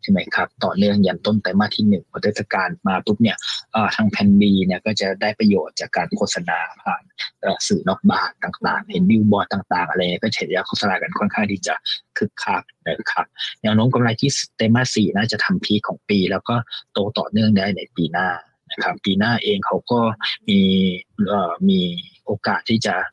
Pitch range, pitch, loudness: 100-125 Hz, 110 Hz, -20 LUFS